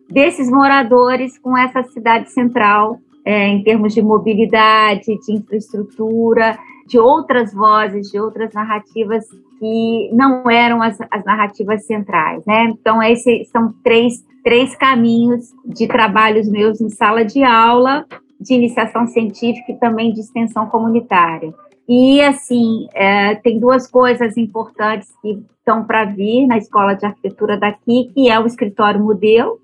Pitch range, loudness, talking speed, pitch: 215-245 Hz, -14 LUFS, 140 wpm, 225 Hz